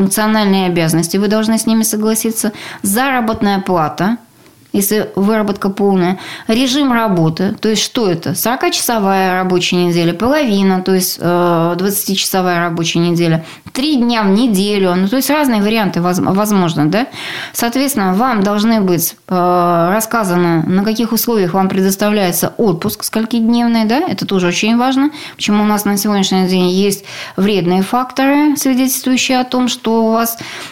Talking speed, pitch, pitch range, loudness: 140 wpm, 205 Hz, 185-230 Hz, -13 LUFS